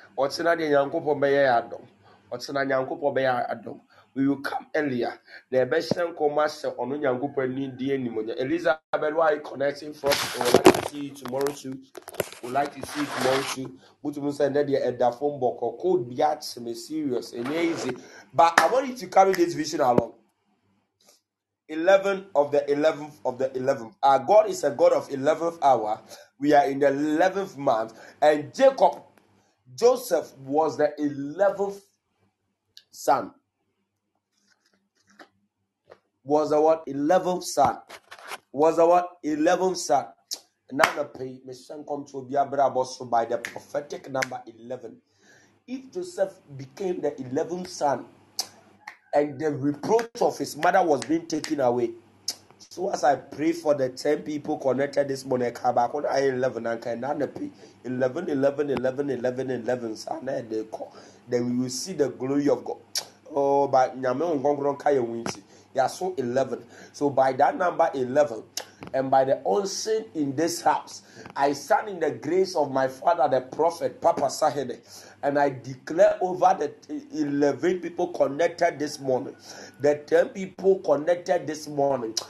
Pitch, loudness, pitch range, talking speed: 145 Hz, -25 LUFS, 130-170 Hz, 140 wpm